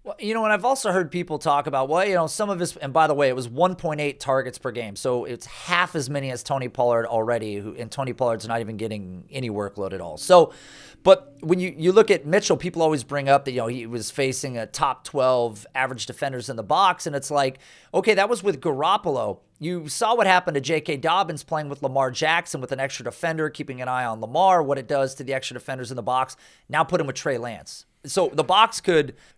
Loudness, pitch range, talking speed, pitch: -23 LUFS, 125-170 Hz, 250 wpm, 140 Hz